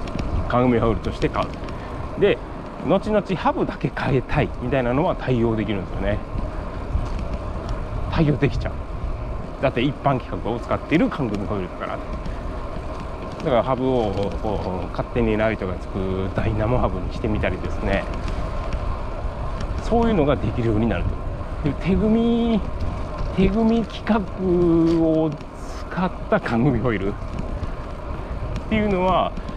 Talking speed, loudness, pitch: 270 characters per minute, -23 LUFS, 110 Hz